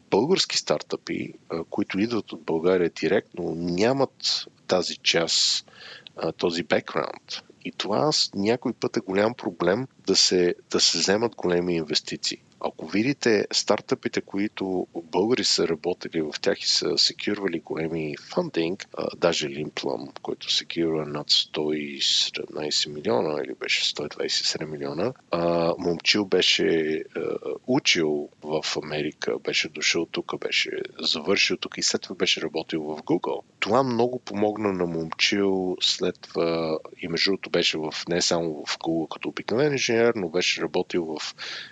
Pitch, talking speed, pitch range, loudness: 90 Hz, 135 wpm, 80-115 Hz, -24 LUFS